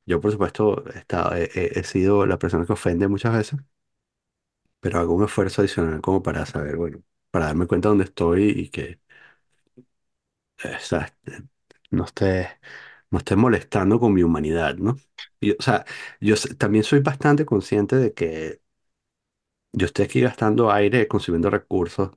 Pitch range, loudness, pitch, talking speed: 85-110 Hz, -22 LUFS, 100 Hz, 160 wpm